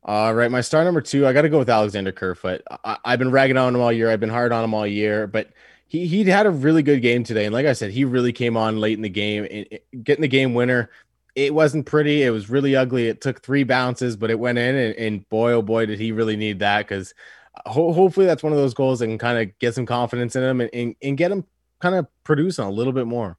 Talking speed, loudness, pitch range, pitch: 275 wpm, -20 LUFS, 110-140 Hz, 120 Hz